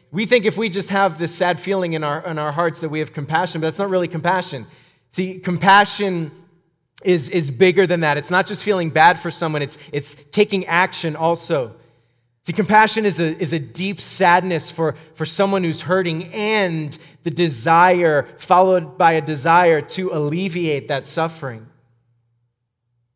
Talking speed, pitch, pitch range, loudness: 170 wpm, 165 Hz, 150-185 Hz, -18 LUFS